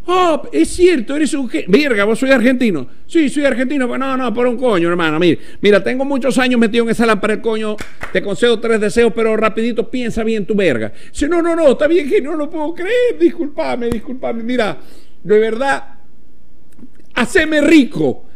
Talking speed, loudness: 195 wpm, -15 LUFS